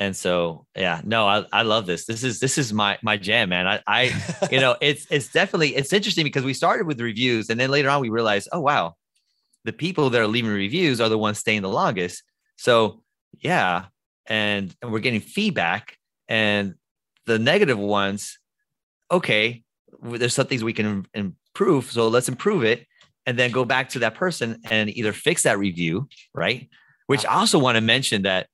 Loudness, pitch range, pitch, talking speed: -21 LUFS, 105-140 Hz, 115 Hz, 195 wpm